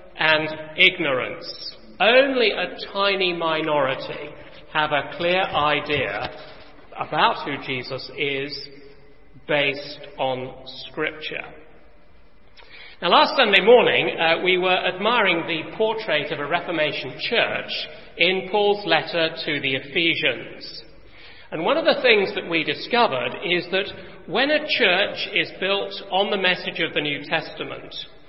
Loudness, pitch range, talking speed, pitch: -21 LUFS, 145-190 Hz, 125 wpm, 165 Hz